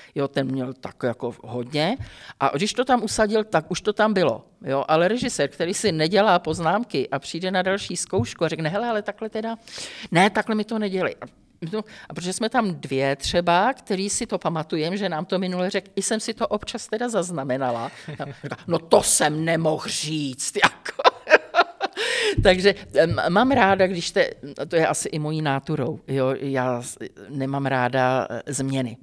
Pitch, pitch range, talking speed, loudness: 170 Hz, 140-210 Hz, 180 wpm, -23 LUFS